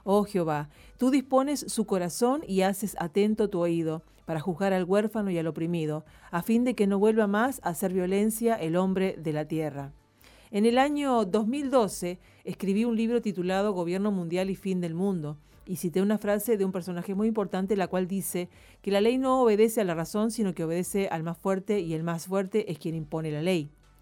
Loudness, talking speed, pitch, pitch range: -28 LUFS, 205 wpm, 190 Hz, 170-215 Hz